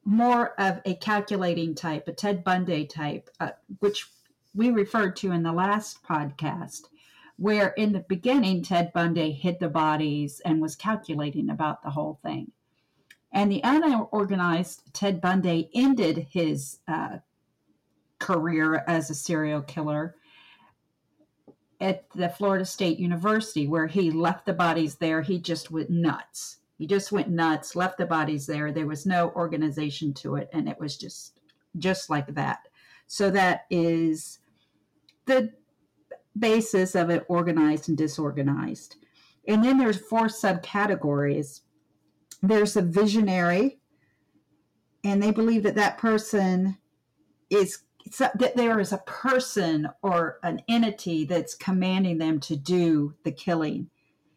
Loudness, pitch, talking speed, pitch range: -26 LUFS, 175 Hz, 135 wpm, 155-205 Hz